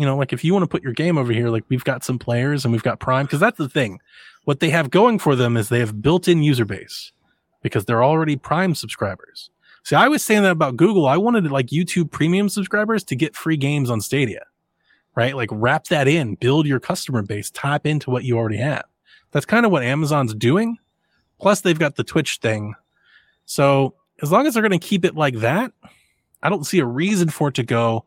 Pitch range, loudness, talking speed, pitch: 125-180 Hz, -19 LUFS, 230 wpm, 145 Hz